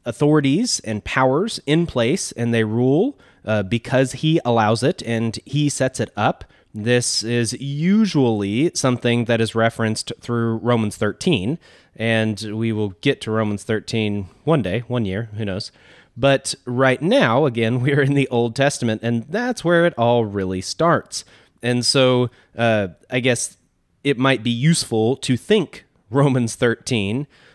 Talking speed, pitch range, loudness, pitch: 155 wpm, 110-140 Hz, -20 LUFS, 120 Hz